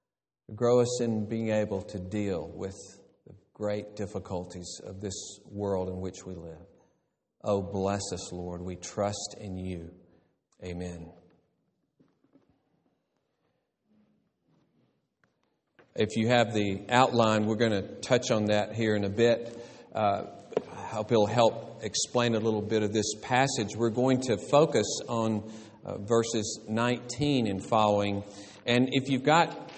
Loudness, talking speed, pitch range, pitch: -29 LUFS, 135 wpm, 95-115 Hz, 105 Hz